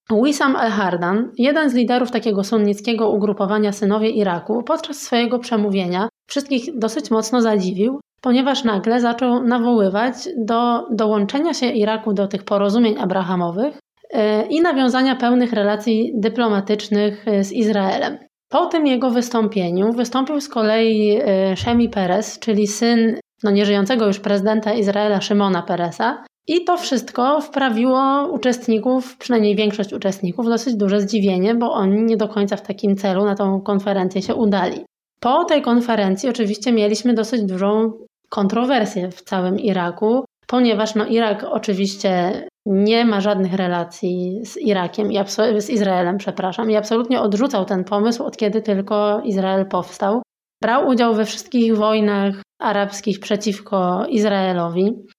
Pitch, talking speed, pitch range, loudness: 215 Hz, 130 wpm, 200-240 Hz, -18 LUFS